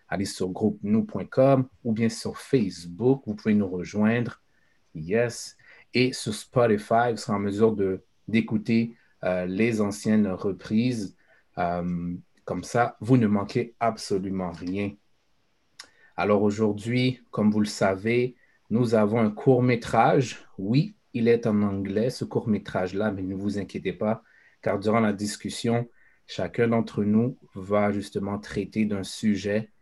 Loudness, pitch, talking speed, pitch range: -26 LUFS, 110 Hz, 135 wpm, 100-115 Hz